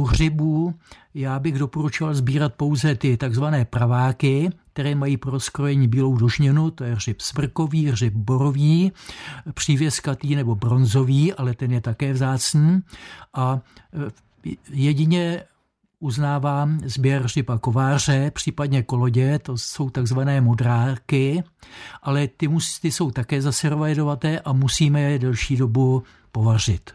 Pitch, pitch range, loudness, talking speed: 140 Hz, 130-150 Hz, -21 LUFS, 120 wpm